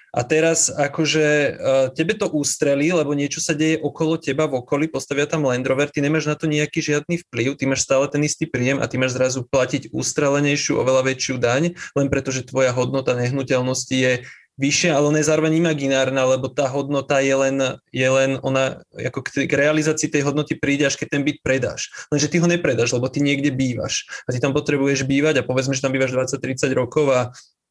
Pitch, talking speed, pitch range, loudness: 140 Hz, 200 wpm, 130-150 Hz, -20 LUFS